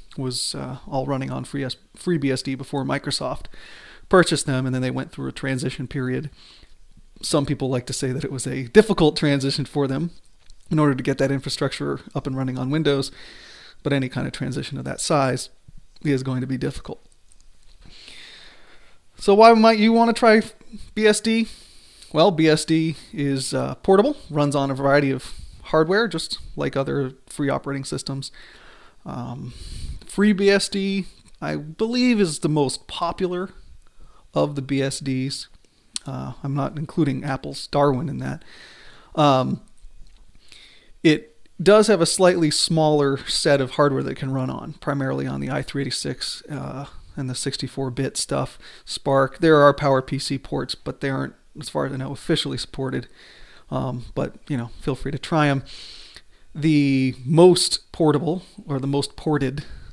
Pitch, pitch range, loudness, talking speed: 140 Hz, 130-160 Hz, -22 LUFS, 155 wpm